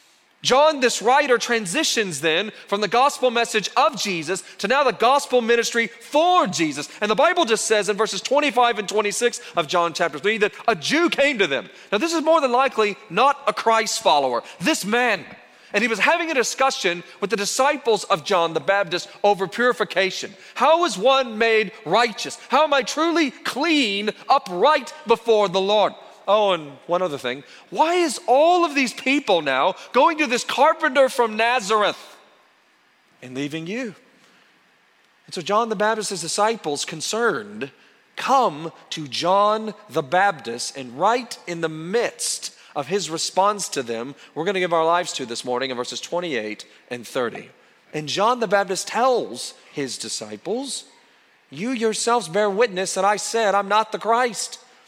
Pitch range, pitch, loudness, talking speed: 185-255 Hz, 215 Hz, -21 LUFS, 170 wpm